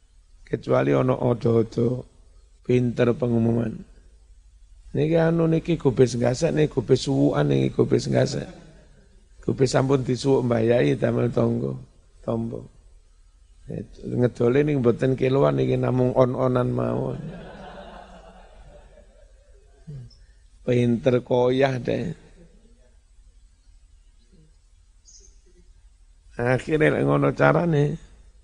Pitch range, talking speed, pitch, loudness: 80-130 Hz, 85 wpm, 115 Hz, -22 LUFS